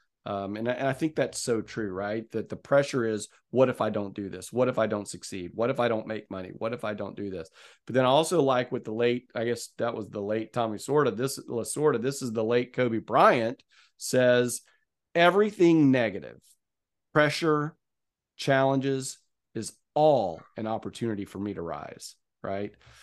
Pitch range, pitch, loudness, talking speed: 105-135 Hz, 115 Hz, -27 LUFS, 195 wpm